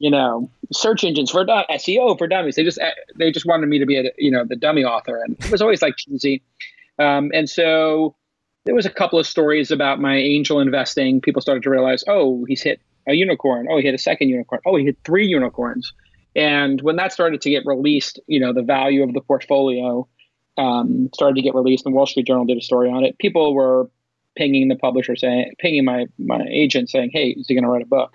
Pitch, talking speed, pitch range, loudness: 140 Hz, 235 wpm, 130-155 Hz, -18 LUFS